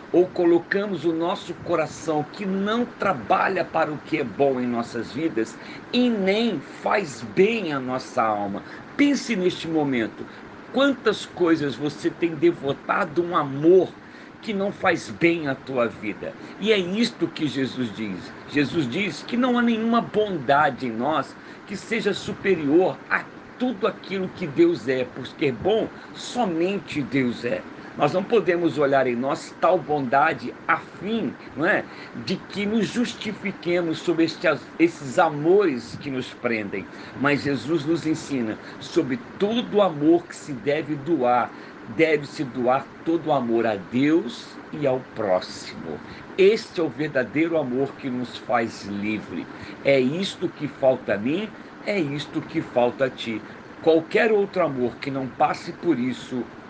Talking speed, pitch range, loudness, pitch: 150 wpm, 135-200 Hz, -24 LUFS, 165 Hz